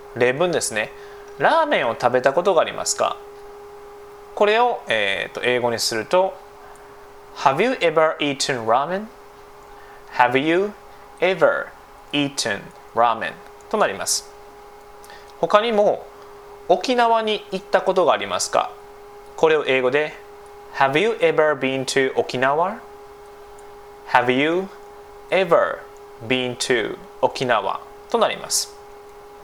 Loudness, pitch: -20 LUFS, 205 Hz